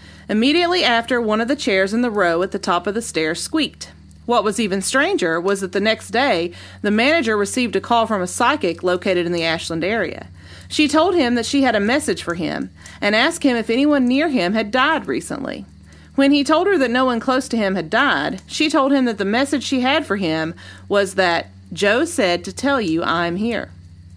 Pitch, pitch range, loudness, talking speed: 225 Hz, 180-270 Hz, -18 LUFS, 220 wpm